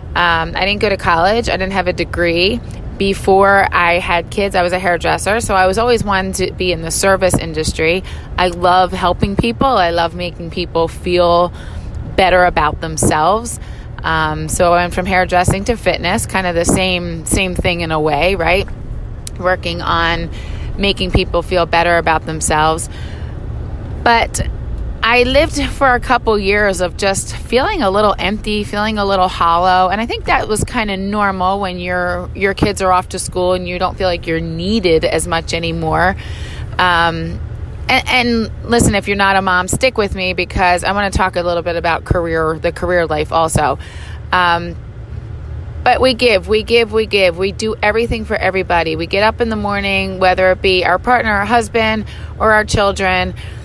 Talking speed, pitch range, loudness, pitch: 185 wpm, 170-200 Hz, -14 LUFS, 180 Hz